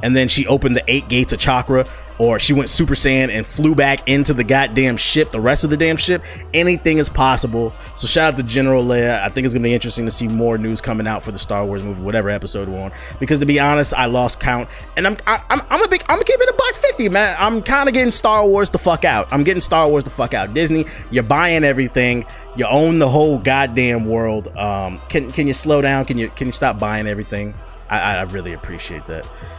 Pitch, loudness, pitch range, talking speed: 130 Hz, -16 LUFS, 115-155 Hz, 245 wpm